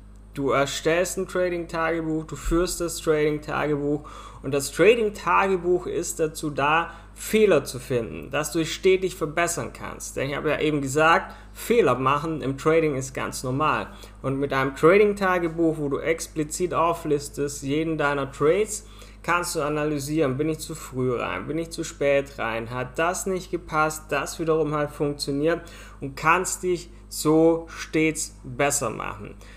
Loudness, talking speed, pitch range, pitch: -24 LUFS, 150 wpm, 140-165 Hz, 155 Hz